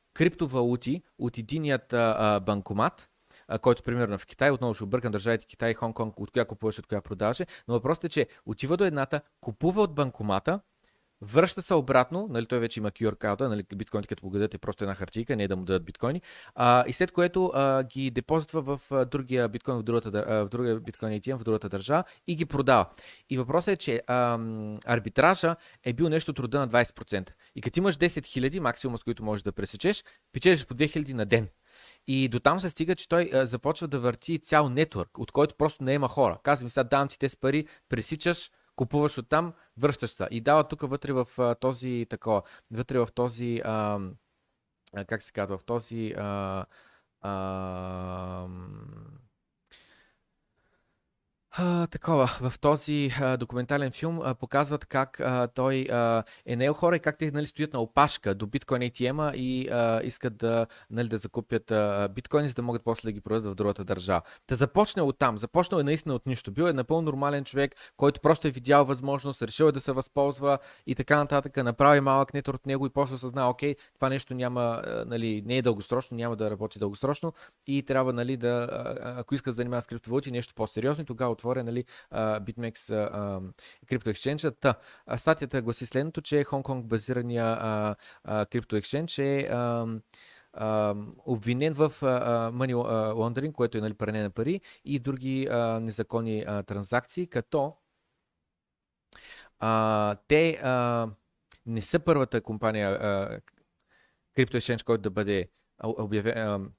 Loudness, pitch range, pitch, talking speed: -28 LUFS, 110-140 Hz, 125 Hz, 170 wpm